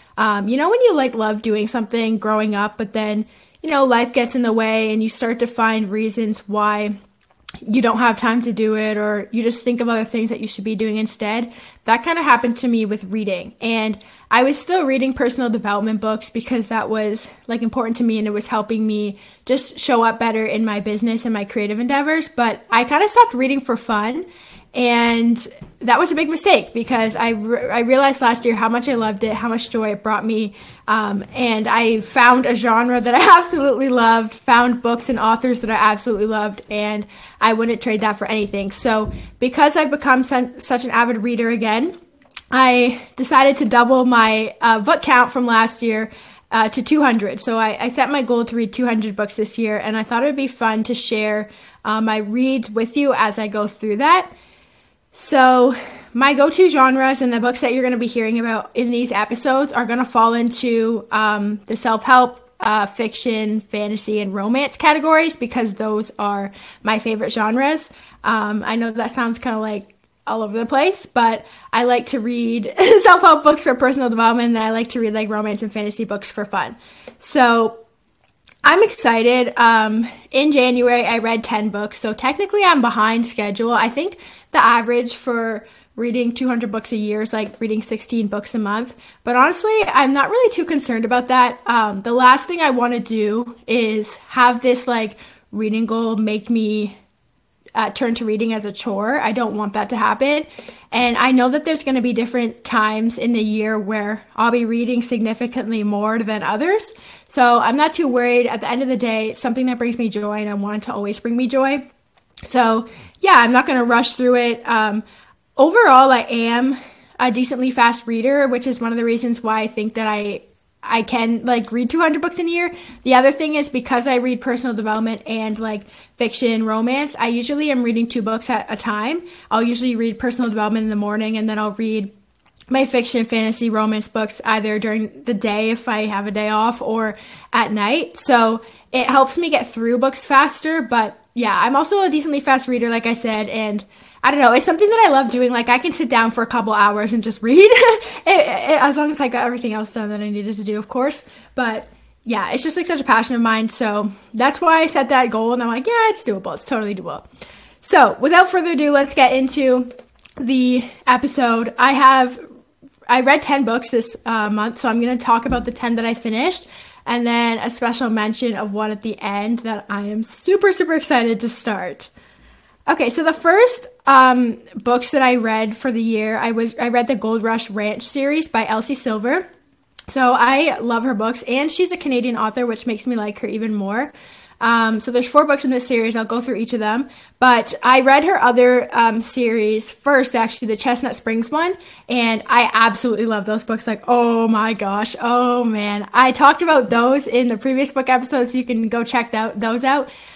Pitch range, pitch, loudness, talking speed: 220-255 Hz, 235 Hz, -17 LUFS, 210 wpm